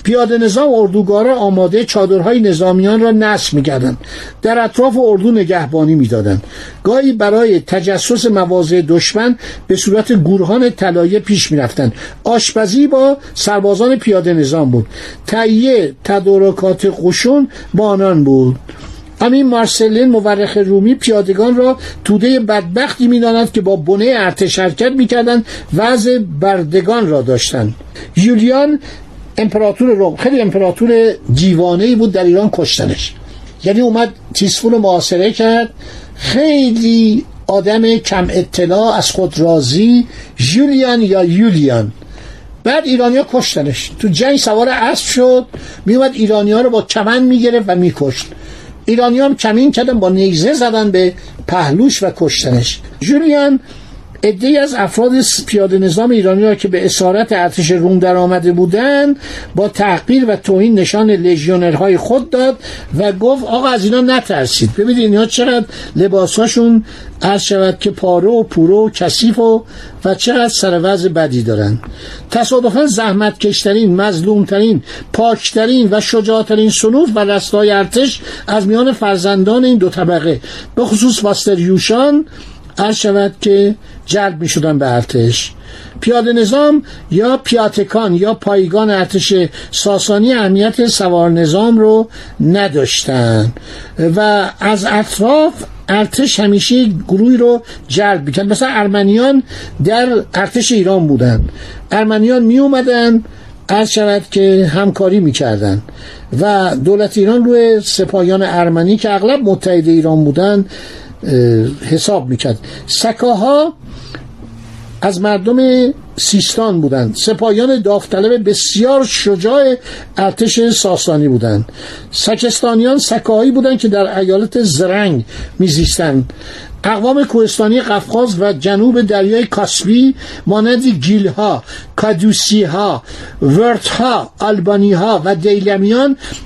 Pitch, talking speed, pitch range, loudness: 205 Hz, 120 wpm, 185-235 Hz, -11 LUFS